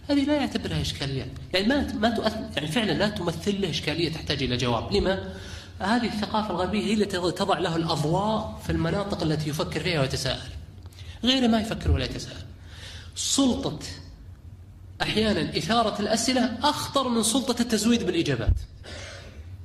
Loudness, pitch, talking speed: -25 LUFS, 175 Hz, 145 wpm